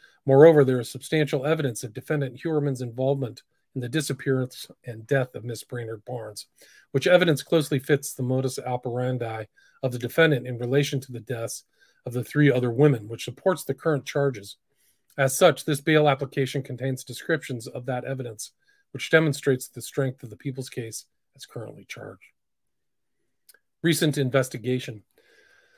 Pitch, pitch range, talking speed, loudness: 135 Hz, 125-150 Hz, 155 wpm, -25 LUFS